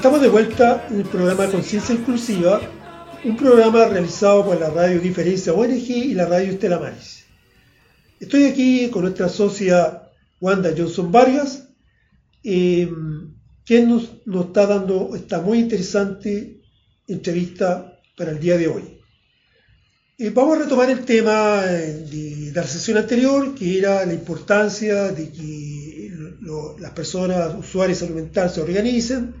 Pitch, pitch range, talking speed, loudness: 195 Hz, 175-230 Hz, 135 wpm, -18 LUFS